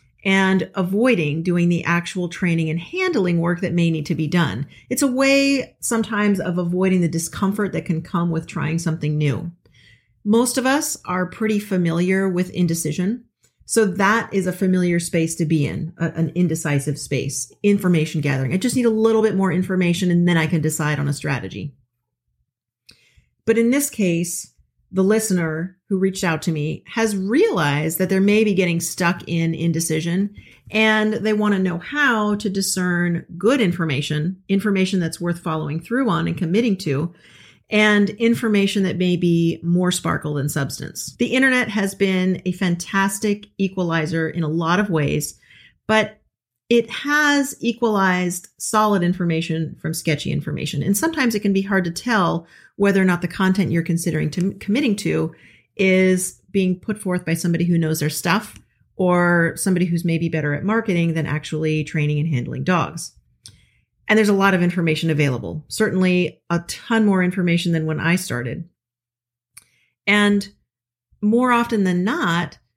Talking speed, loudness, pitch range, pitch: 165 wpm, -20 LUFS, 160-200 Hz, 175 Hz